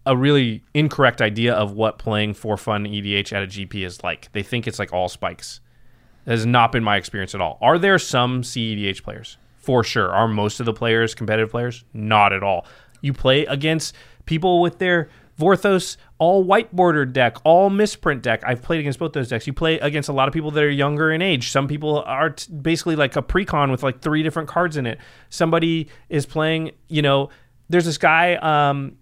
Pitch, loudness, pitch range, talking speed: 135 Hz, -20 LUFS, 115-160 Hz, 210 wpm